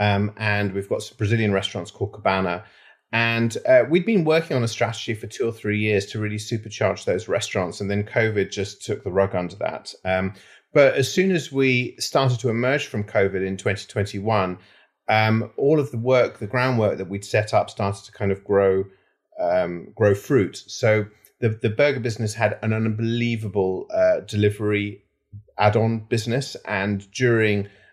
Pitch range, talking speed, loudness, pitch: 100-120 Hz, 175 wpm, -22 LUFS, 105 Hz